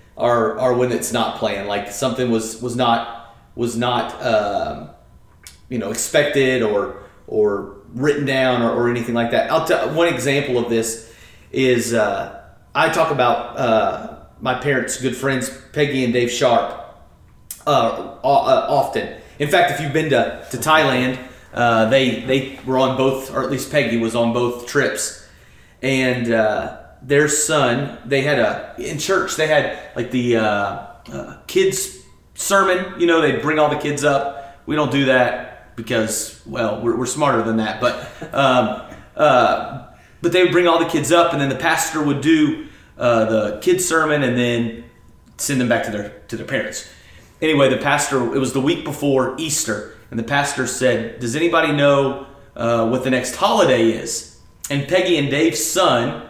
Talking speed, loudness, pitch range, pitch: 175 wpm, -18 LUFS, 115-145 Hz, 130 Hz